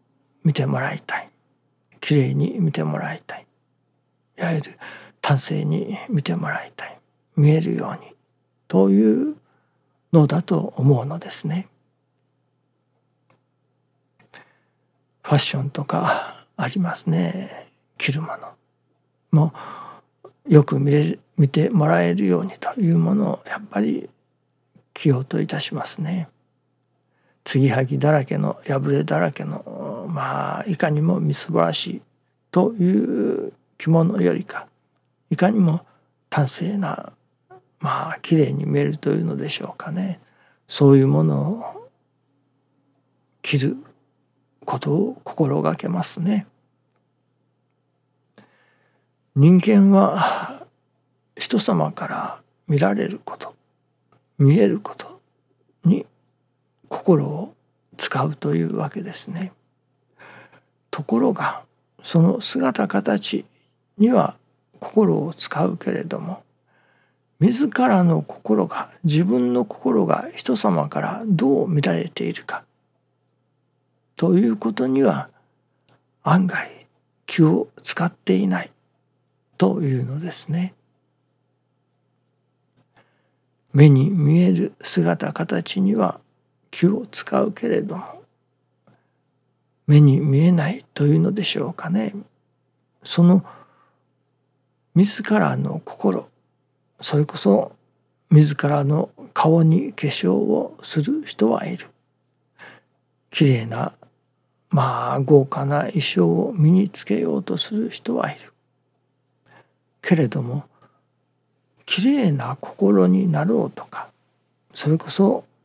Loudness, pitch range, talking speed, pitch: -20 LUFS, 135-175 Hz, 195 characters per minute, 145 Hz